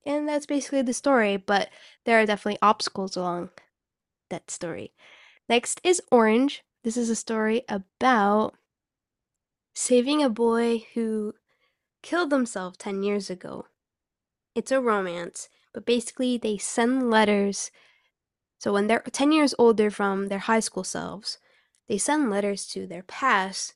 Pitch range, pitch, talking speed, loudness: 200-255 Hz, 225 Hz, 140 wpm, -25 LUFS